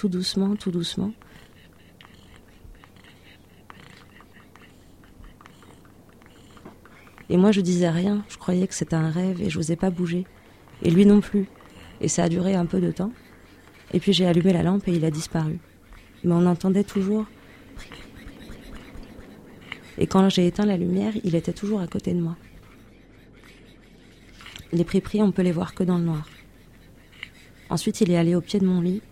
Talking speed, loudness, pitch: 160 wpm, -23 LUFS, 175 Hz